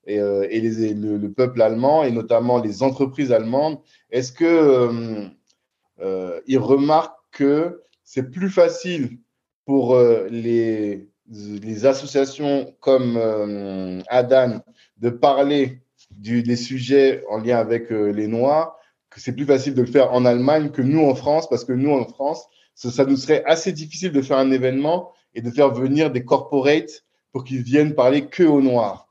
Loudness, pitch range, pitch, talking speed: -19 LUFS, 115-145 Hz, 130 Hz, 170 wpm